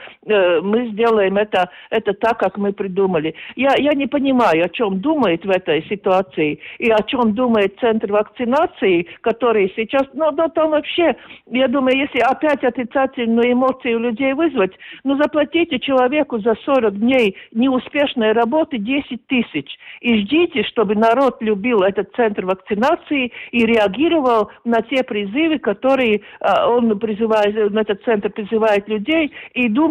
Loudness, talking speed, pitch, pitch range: -17 LUFS, 140 wpm, 235 Hz, 210-270 Hz